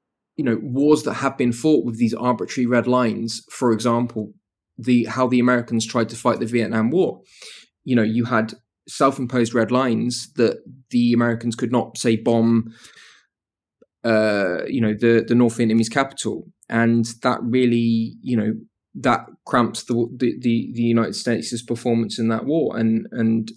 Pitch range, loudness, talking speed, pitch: 115-125 Hz, -20 LUFS, 165 wpm, 115 Hz